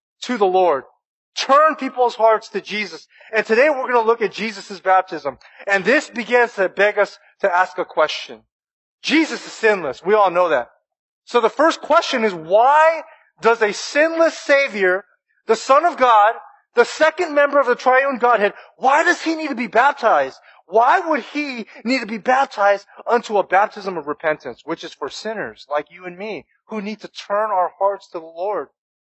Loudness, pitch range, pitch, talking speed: -18 LUFS, 195-280 Hz, 225 Hz, 190 wpm